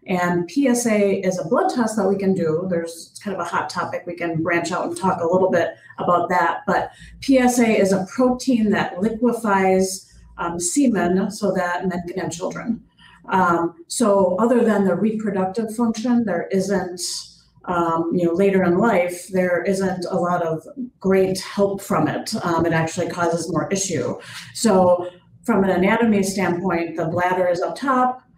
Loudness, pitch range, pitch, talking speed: -20 LUFS, 175-210 Hz, 185 Hz, 175 wpm